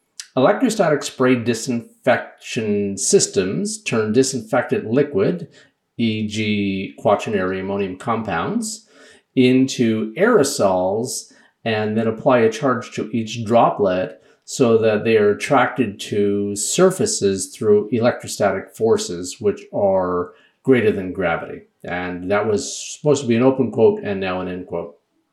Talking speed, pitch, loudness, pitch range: 120 wpm, 115 Hz, -19 LUFS, 100-145 Hz